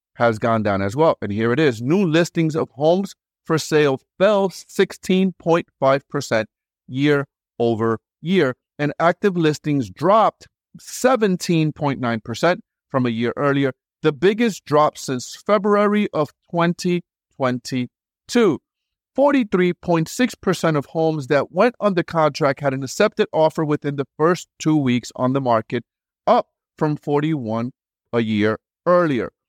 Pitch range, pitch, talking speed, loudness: 130-175 Hz, 150 Hz, 125 wpm, -20 LUFS